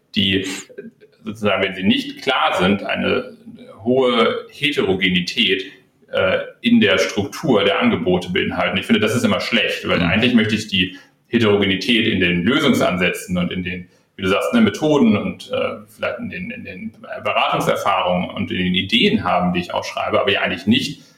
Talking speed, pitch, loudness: 170 wpm, 115 Hz, -18 LUFS